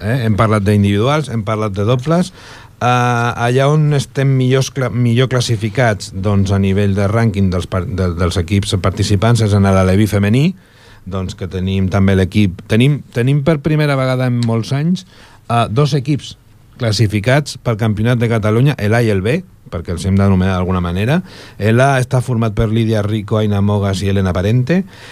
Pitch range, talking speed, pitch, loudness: 100-125 Hz, 170 wpm, 110 Hz, -15 LUFS